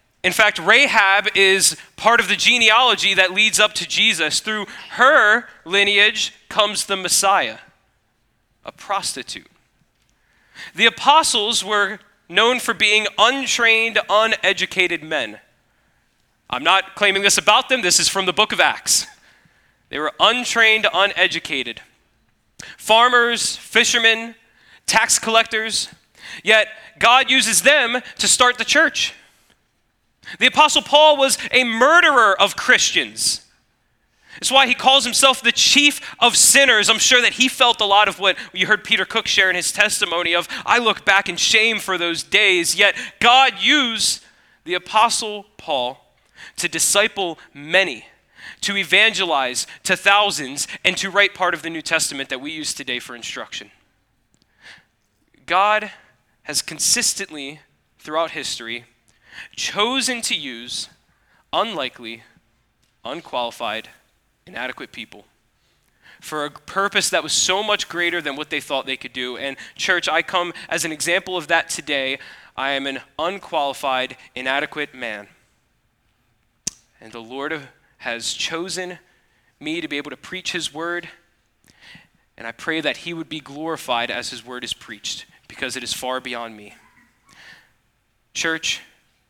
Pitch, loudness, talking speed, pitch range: 195 Hz, -16 LUFS, 140 wpm, 160-225 Hz